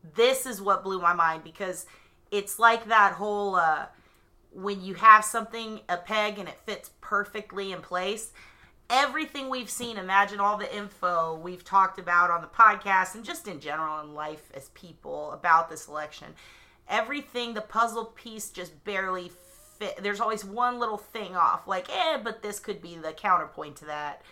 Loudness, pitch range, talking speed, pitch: -26 LUFS, 175-225 Hz, 175 wpm, 200 Hz